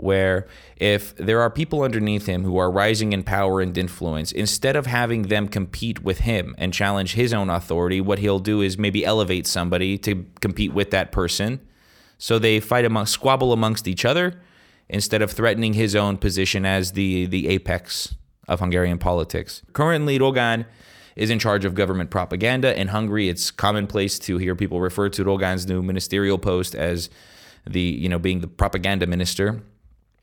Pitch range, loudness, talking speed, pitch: 90-110 Hz, -22 LUFS, 175 wpm, 100 Hz